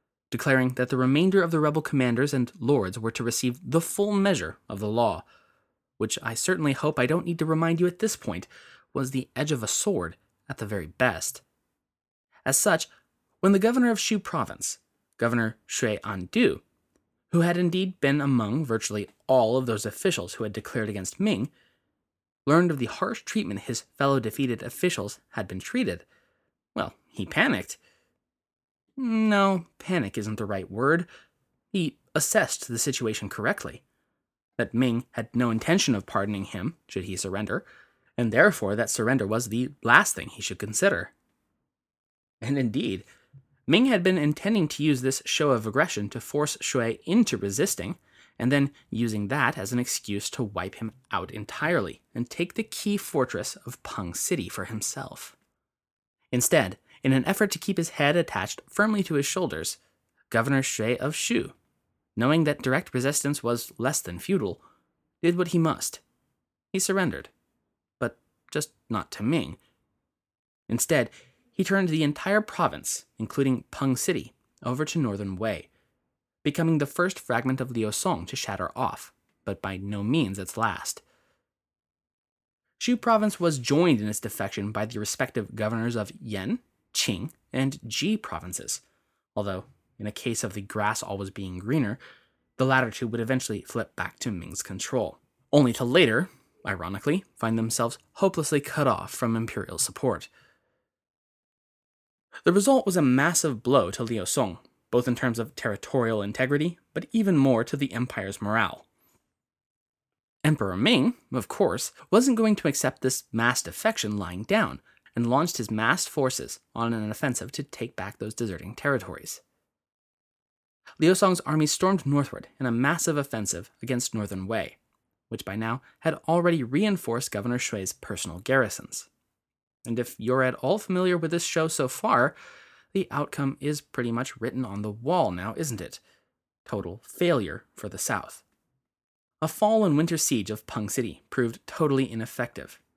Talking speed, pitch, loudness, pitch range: 160 wpm, 130 Hz, -26 LUFS, 110-165 Hz